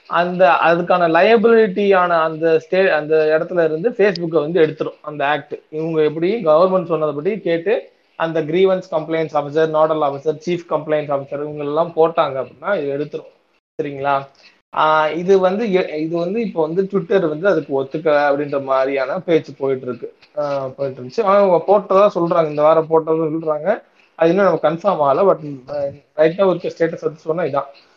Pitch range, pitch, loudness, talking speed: 150-185 Hz, 160 Hz, -17 LUFS, 150 wpm